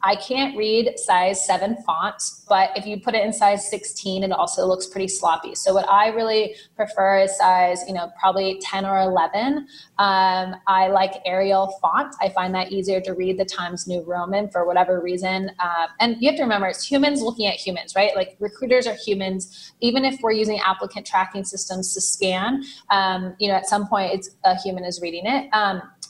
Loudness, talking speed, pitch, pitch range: -21 LUFS, 200 wpm, 195 Hz, 185-210 Hz